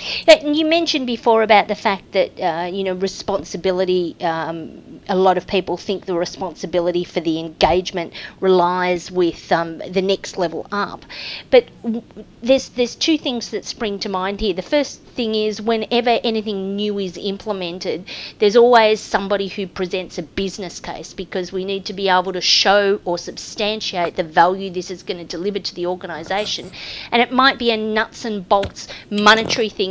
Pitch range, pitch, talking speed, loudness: 180-220 Hz, 195 Hz, 175 wpm, -19 LUFS